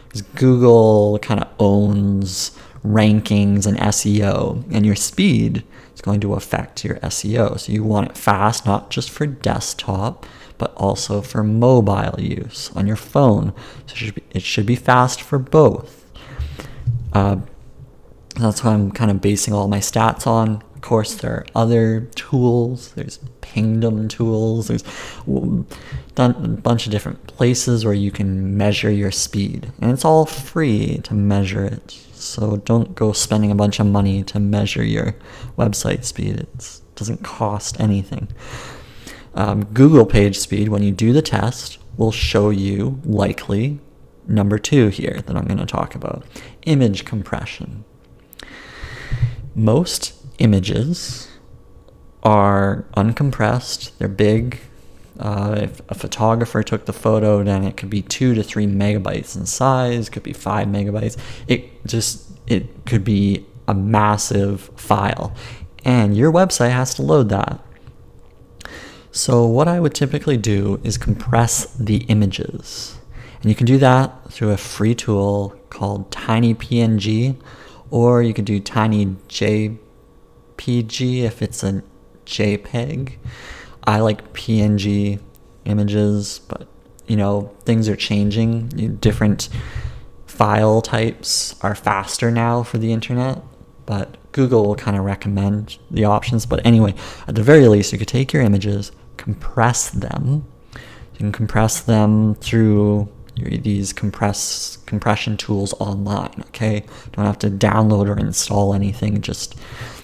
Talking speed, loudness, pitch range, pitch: 140 wpm, -18 LUFS, 100-120 Hz, 110 Hz